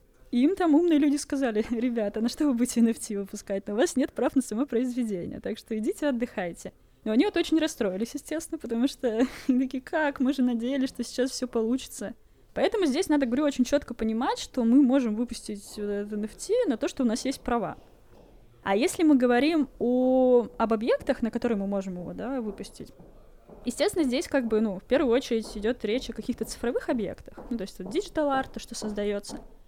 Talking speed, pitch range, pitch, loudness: 200 wpm, 225-275 Hz, 245 Hz, -27 LUFS